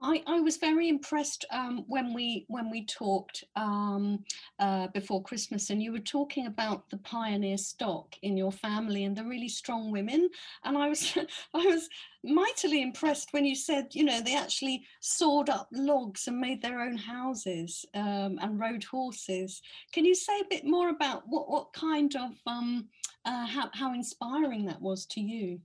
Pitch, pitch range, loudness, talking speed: 245 Hz, 205-295 Hz, -32 LUFS, 180 wpm